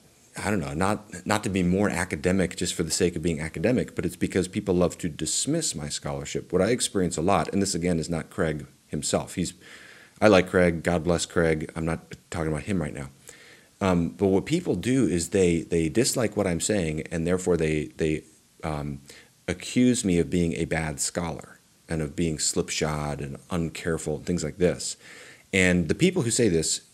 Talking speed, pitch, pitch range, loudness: 205 wpm, 90 Hz, 80-95 Hz, -26 LUFS